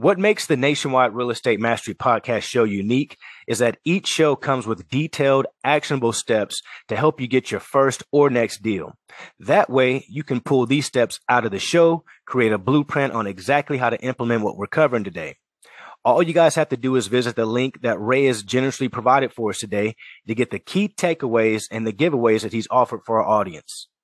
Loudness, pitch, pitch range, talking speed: -20 LUFS, 130 Hz, 115-145 Hz, 205 wpm